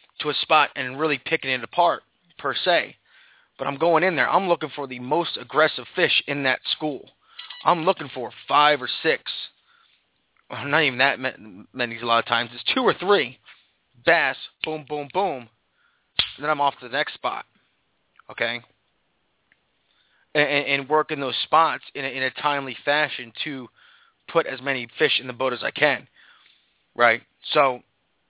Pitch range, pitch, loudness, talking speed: 125-155 Hz, 140 Hz, -22 LUFS, 175 wpm